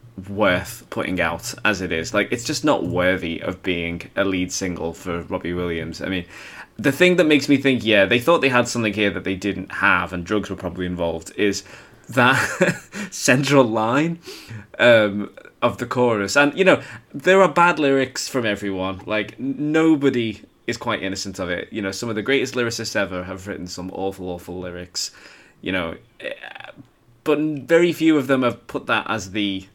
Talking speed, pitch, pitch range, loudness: 190 wpm, 105 Hz, 95-135 Hz, -20 LUFS